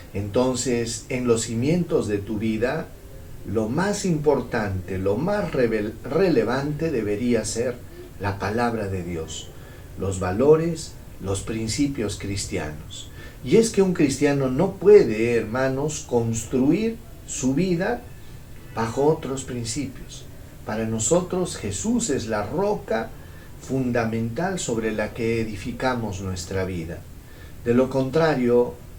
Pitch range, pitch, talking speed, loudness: 105-135 Hz, 120 Hz, 115 wpm, -23 LUFS